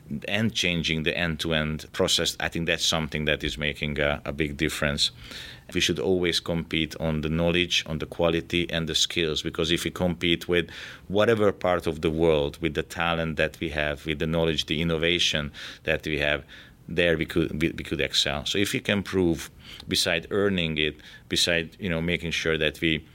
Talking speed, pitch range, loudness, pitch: 195 wpm, 80-85 Hz, -25 LUFS, 80 Hz